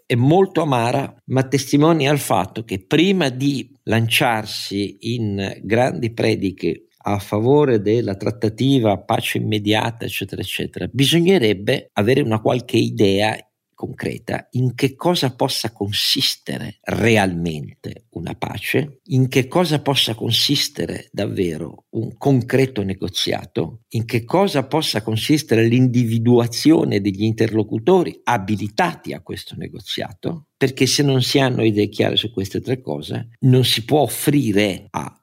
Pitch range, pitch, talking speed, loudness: 105-140 Hz, 120 Hz, 125 wpm, -19 LUFS